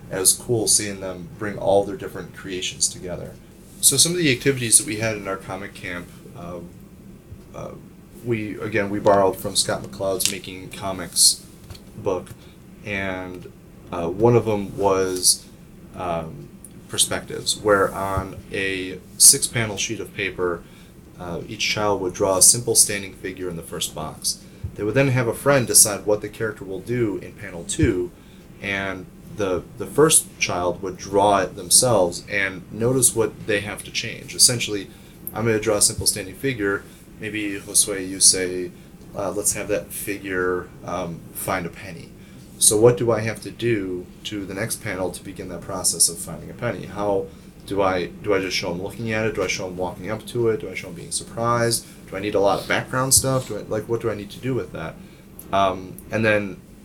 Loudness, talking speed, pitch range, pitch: -20 LUFS, 190 wpm, 95-115 Hz, 100 Hz